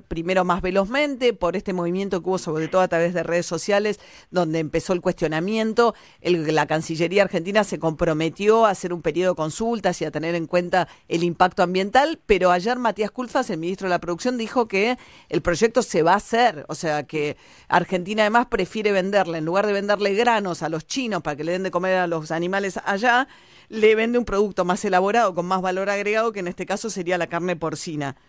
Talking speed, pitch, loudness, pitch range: 210 wpm, 185 Hz, -22 LUFS, 170-215 Hz